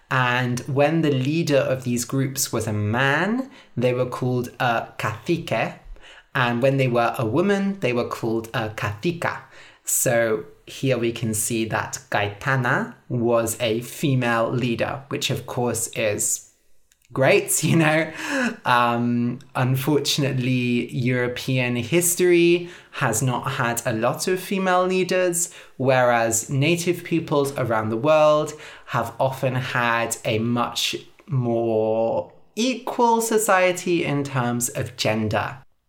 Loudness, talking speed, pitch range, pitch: -22 LUFS, 125 wpm, 120-155 Hz, 130 Hz